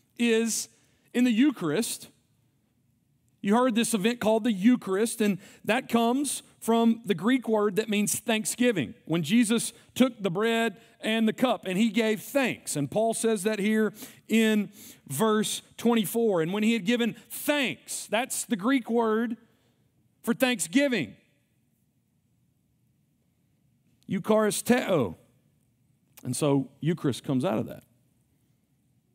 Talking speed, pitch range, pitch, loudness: 130 wpm, 200-235 Hz, 225 Hz, -26 LUFS